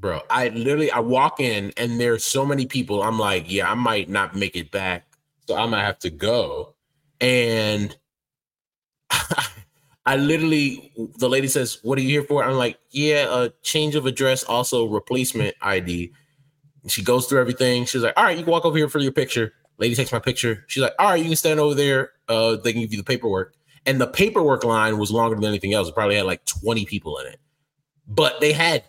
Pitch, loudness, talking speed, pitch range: 130 Hz, -21 LUFS, 220 wpm, 115-145 Hz